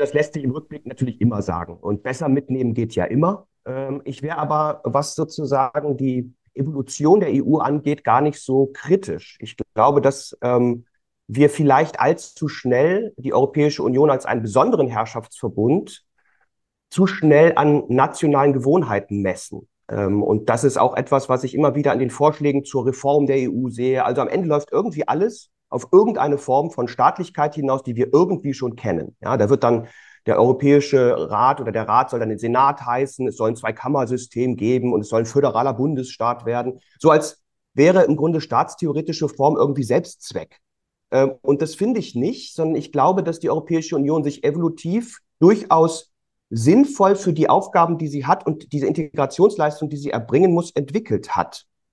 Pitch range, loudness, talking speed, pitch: 125-155 Hz, -19 LUFS, 170 wpm, 140 Hz